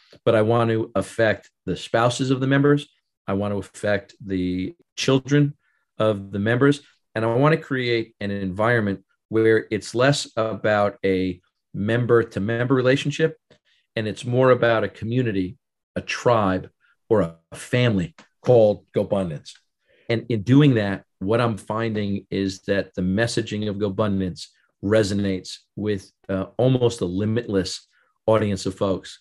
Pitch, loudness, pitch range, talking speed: 110 Hz, -22 LUFS, 100-120 Hz, 145 wpm